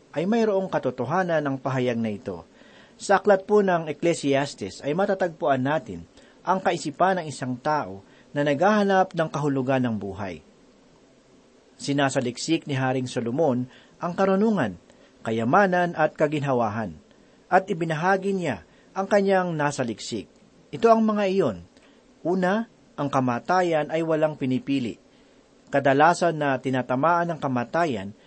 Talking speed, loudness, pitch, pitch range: 120 wpm, -24 LUFS, 150 Hz, 130-185 Hz